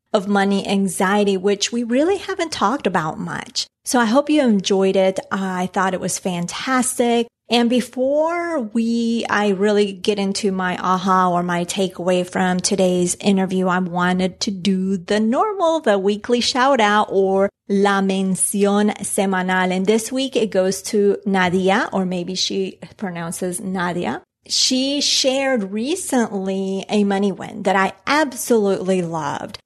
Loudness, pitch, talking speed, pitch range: -19 LUFS, 200 Hz, 145 wpm, 185-235 Hz